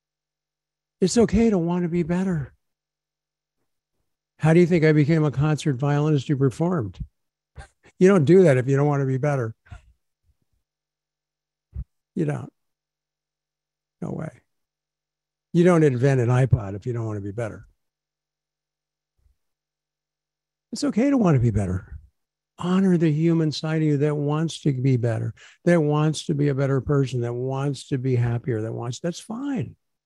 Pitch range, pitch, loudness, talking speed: 125-170 Hz, 150 Hz, -22 LUFS, 160 wpm